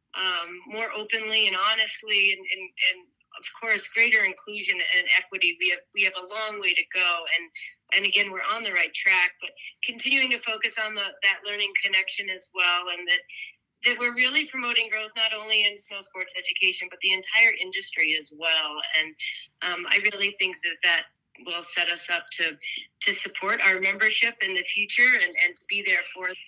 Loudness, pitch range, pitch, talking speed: -23 LUFS, 185-235 Hz, 205 Hz, 195 wpm